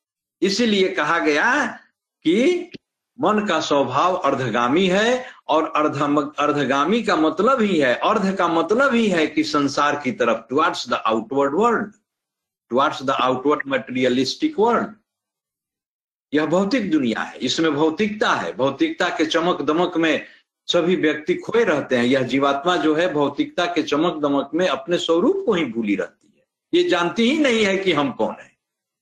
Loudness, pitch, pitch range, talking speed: -20 LUFS, 170 Hz, 145-215 Hz, 155 wpm